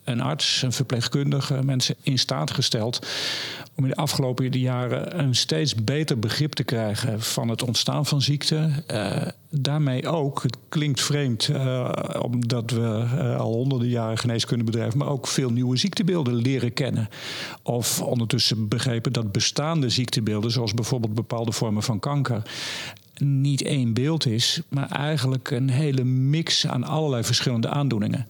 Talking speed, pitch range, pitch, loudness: 150 wpm, 120-145 Hz, 130 Hz, -24 LUFS